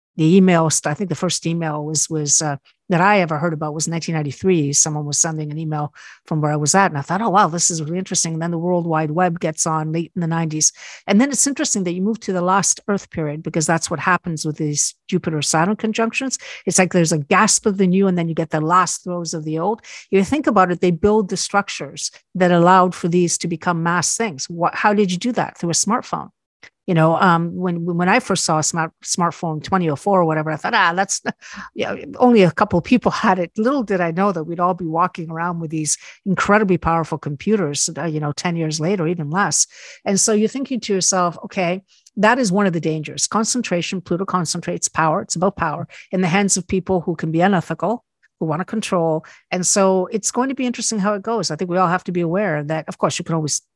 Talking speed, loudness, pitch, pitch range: 245 wpm, -18 LUFS, 175 Hz, 160-195 Hz